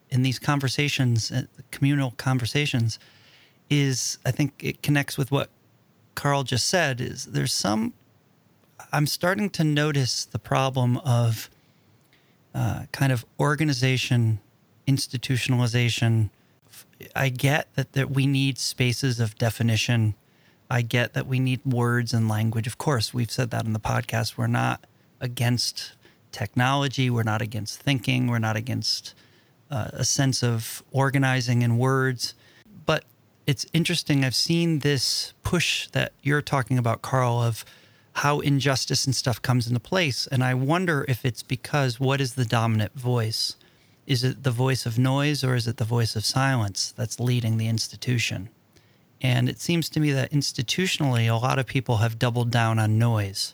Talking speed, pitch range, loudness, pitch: 155 wpm, 115-140 Hz, -24 LUFS, 130 Hz